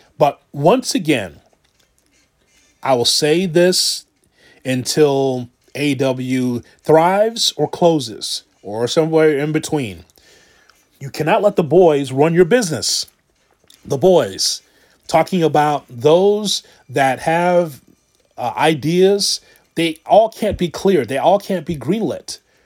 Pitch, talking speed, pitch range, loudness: 155 Hz, 115 wpm, 135-180 Hz, -16 LUFS